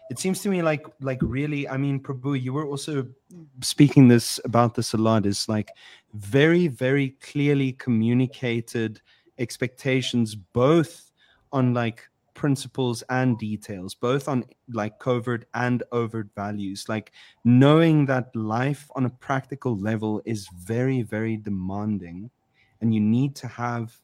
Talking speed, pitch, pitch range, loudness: 140 wpm, 125 Hz, 110-140 Hz, -24 LUFS